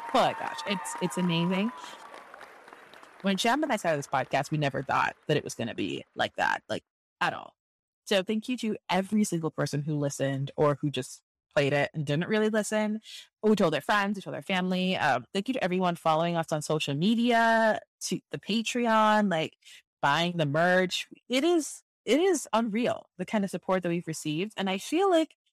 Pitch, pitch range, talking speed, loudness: 185 Hz, 160-220 Hz, 200 wpm, -28 LUFS